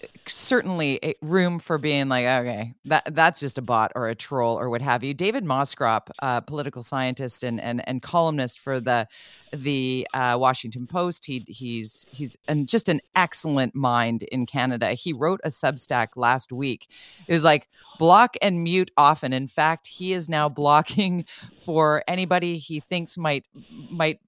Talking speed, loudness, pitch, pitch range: 165 wpm, -23 LUFS, 145 Hz, 125-165 Hz